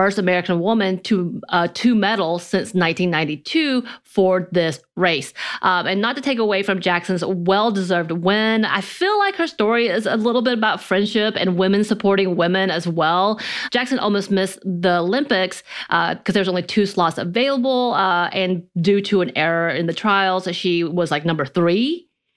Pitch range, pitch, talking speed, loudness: 175-220 Hz, 190 Hz, 175 wpm, -19 LUFS